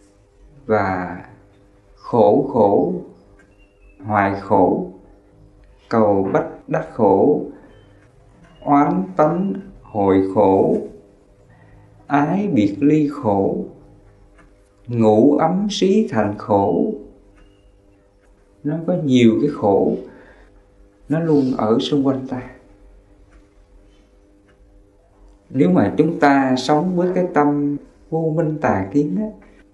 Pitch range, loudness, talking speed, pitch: 100-145 Hz, -18 LUFS, 95 wpm, 100 Hz